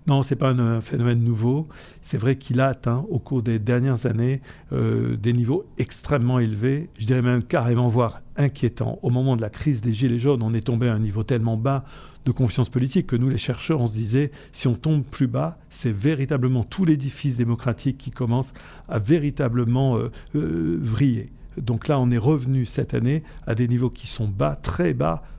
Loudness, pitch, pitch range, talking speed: -23 LUFS, 125 Hz, 120-135 Hz, 205 wpm